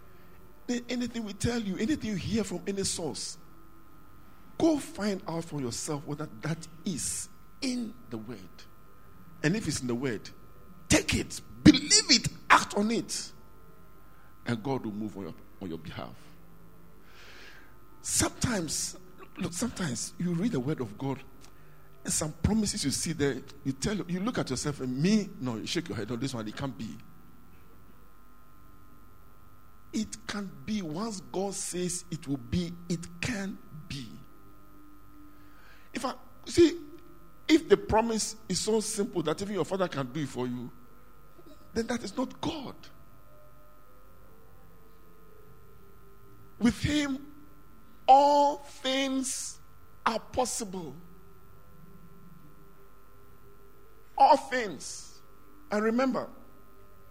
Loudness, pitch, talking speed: -30 LUFS, 155 Hz, 130 wpm